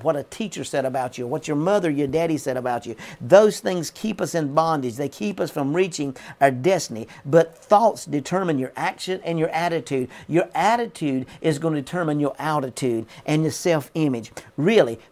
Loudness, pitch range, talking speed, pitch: -22 LUFS, 135-170 Hz, 190 wpm, 155 Hz